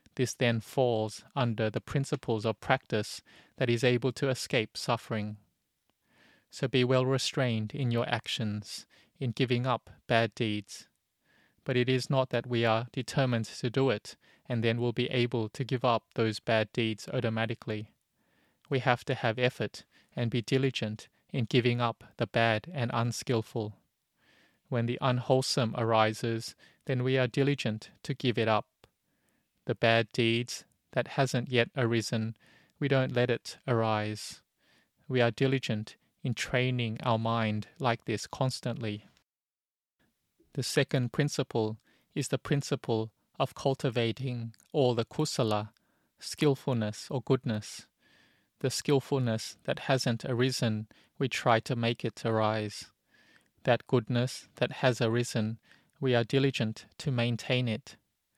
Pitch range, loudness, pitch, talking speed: 110-130 Hz, -31 LUFS, 120 Hz, 140 wpm